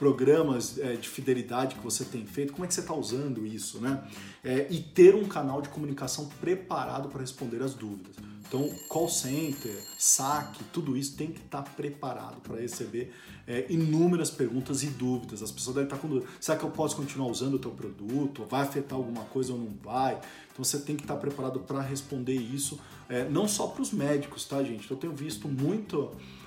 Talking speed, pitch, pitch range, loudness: 205 wpm, 135 Hz, 125-150 Hz, -30 LUFS